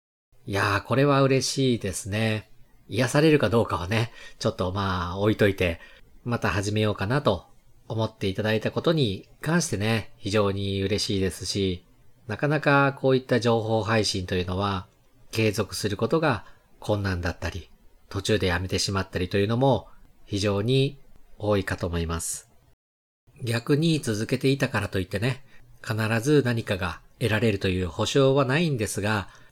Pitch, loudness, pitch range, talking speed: 110 Hz, -25 LUFS, 95-125 Hz, 325 characters per minute